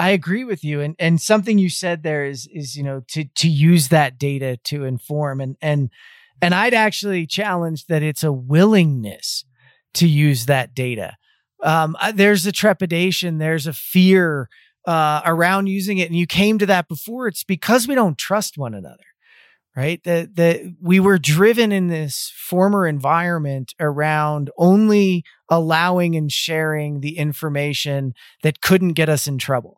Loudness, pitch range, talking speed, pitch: -18 LUFS, 145-190 Hz, 165 wpm, 165 Hz